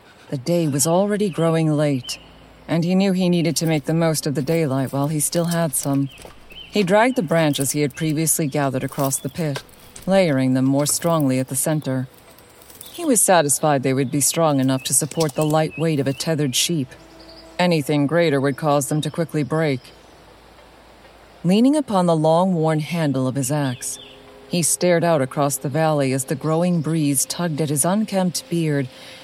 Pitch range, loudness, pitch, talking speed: 140-165 Hz, -20 LUFS, 155 Hz, 185 wpm